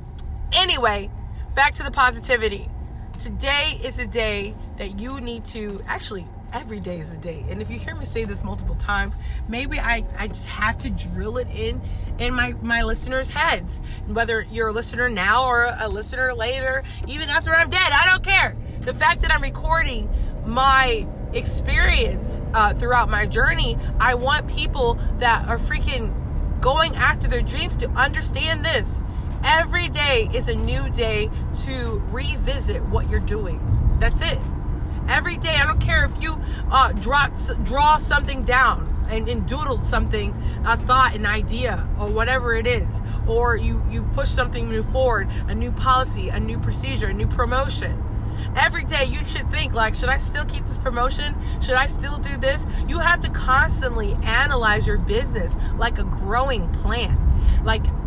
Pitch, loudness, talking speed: 110 Hz, -21 LUFS, 170 wpm